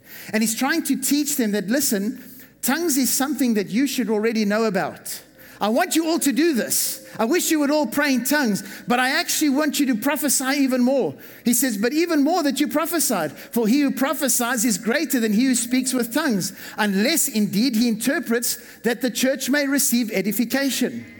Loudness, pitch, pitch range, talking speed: -21 LUFS, 255 Hz, 235-285 Hz, 200 wpm